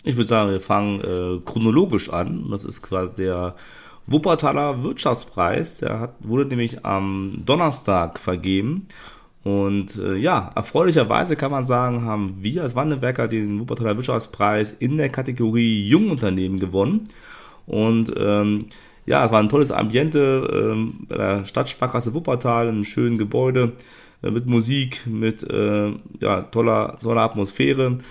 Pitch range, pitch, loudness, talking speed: 105-130 Hz, 115 Hz, -21 LUFS, 140 wpm